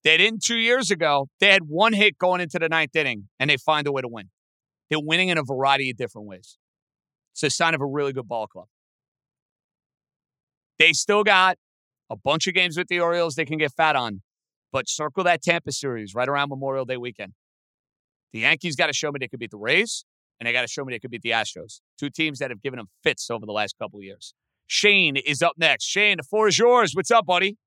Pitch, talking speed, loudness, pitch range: 150 Hz, 240 wpm, -21 LUFS, 125-180 Hz